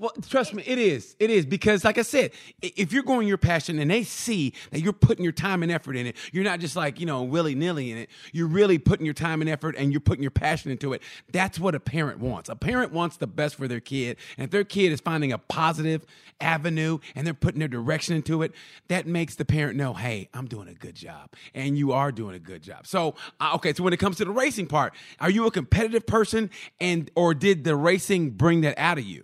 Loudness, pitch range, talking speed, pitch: -25 LUFS, 140-190 Hz, 250 wpm, 160 Hz